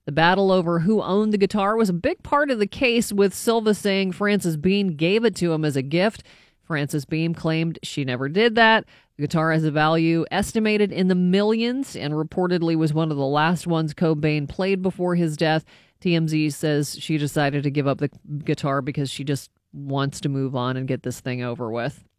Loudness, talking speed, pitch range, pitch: -22 LUFS, 210 wpm, 145-195 Hz, 165 Hz